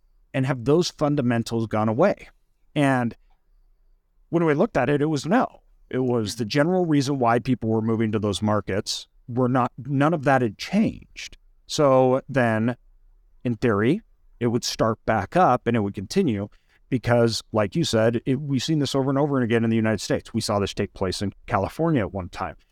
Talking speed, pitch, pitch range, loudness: 195 wpm, 120 Hz, 105-140 Hz, -23 LUFS